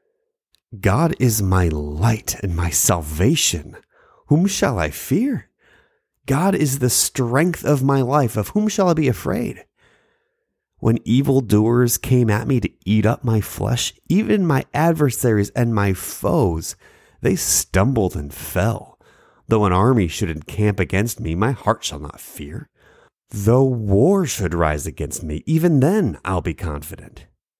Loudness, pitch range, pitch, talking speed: -19 LUFS, 95-135 Hz, 110 Hz, 145 wpm